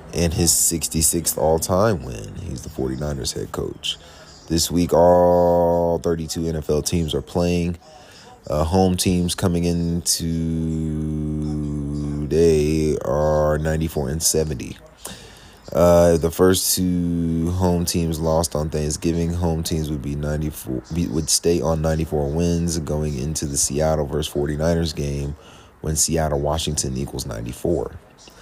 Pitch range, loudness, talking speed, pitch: 75-85 Hz, -20 LUFS, 125 wpm, 80 Hz